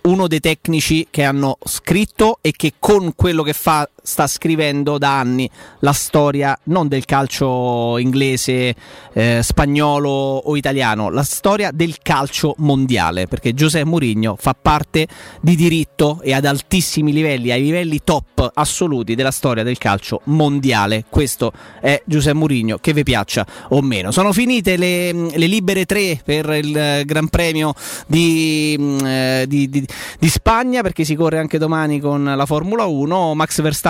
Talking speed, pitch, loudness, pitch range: 155 wpm, 150 Hz, -16 LUFS, 135-160 Hz